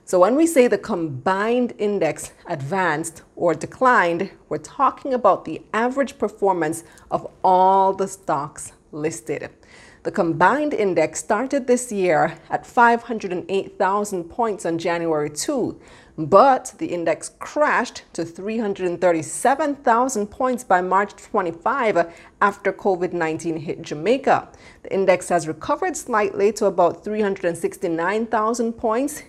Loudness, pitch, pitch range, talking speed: -21 LUFS, 195 Hz, 170-230 Hz, 115 wpm